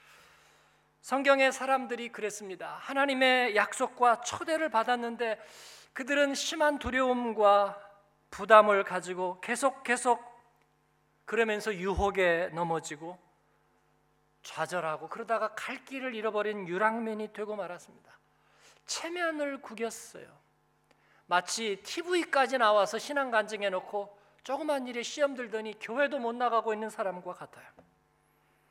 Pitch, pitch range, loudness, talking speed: 225 Hz, 200-260 Hz, -30 LUFS, 270 characters per minute